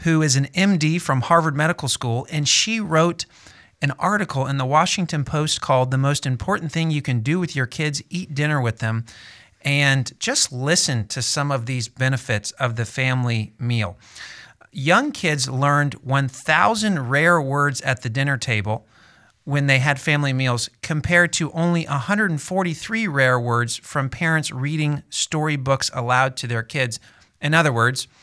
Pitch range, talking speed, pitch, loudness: 125-160 Hz, 160 wpm, 140 Hz, -20 LUFS